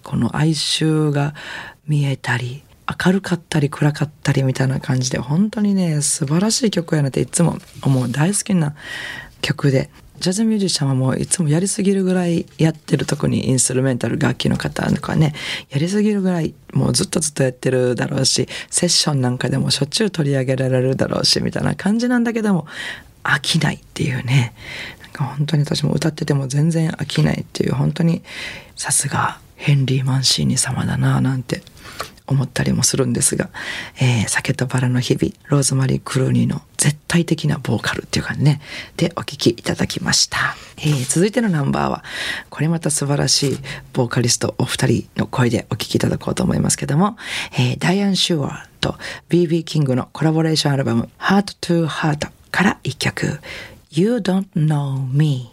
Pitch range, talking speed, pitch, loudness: 130-170 Hz, 410 characters per minute, 150 Hz, -19 LUFS